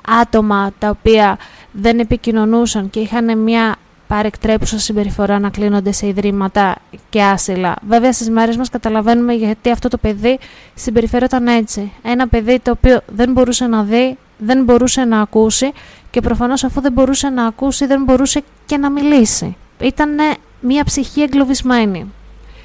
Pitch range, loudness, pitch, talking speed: 210-255 Hz, -14 LUFS, 235 Hz, 145 wpm